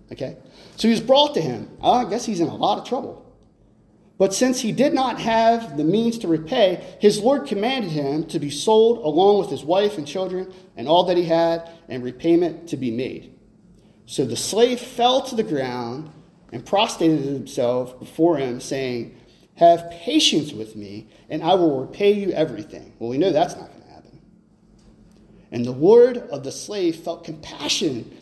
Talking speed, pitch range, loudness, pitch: 185 wpm, 145-220 Hz, -20 LUFS, 170 Hz